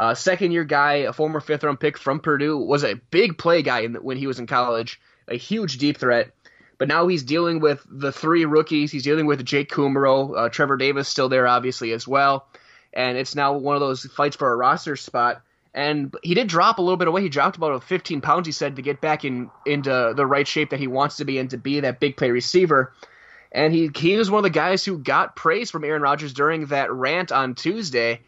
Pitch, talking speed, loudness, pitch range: 145 Hz, 240 wpm, -21 LUFS, 135-155 Hz